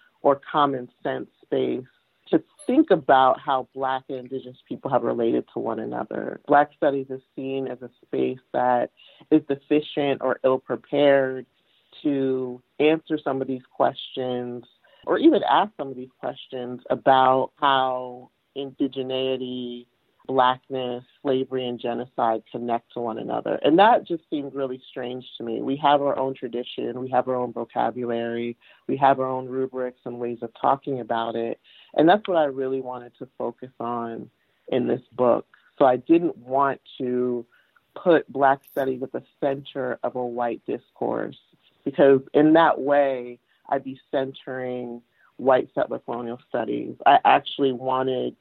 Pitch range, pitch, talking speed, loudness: 125-140 Hz, 130 Hz, 155 wpm, -24 LUFS